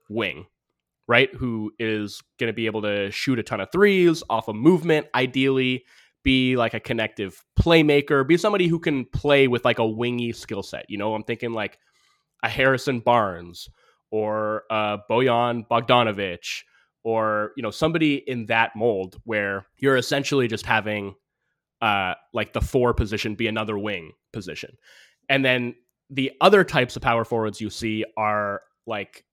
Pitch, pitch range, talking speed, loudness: 115 Hz, 110-135 Hz, 165 wpm, -22 LUFS